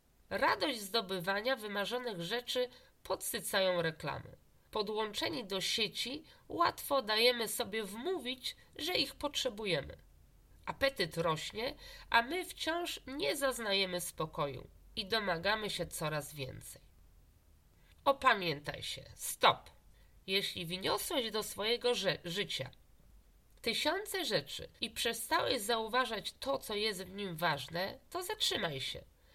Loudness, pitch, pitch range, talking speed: -35 LUFS, 215 Hz, 175-250 Hz, 105 wpm